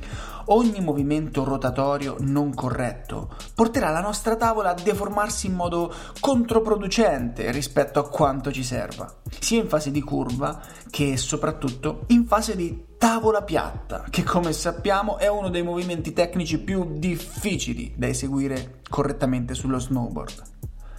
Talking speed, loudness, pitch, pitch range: 130 wpm, -24 LUFS, 160 Hz, 140-205 Hz